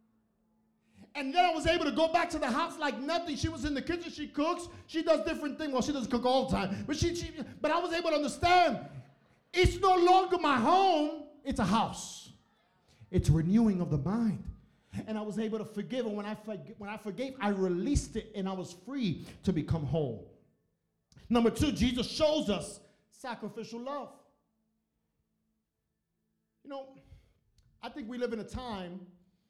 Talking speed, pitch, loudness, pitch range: 185 wpm, 240 Hz, -31 LUFS, 210-305 Hz